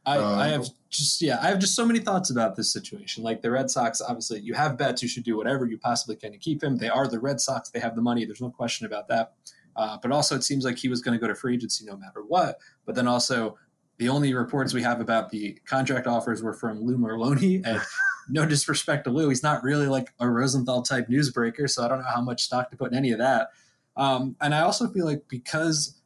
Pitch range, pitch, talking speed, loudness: 120-145 Hz, 125 Hz, 260 wpm, -26 LUFS